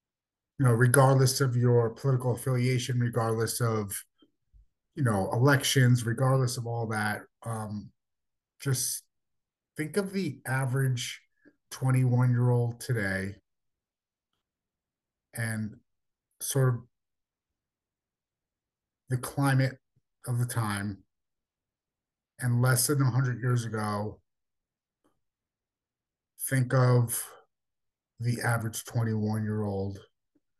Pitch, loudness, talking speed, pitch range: 120 Hz, -28 LUFS, 90 wpm, 110-130 Hz